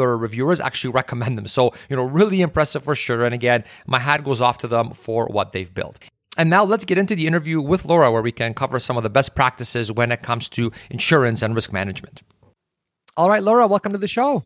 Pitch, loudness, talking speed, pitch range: 130 Hz, -19 LUFS, 230 wpm, 120-165 Hz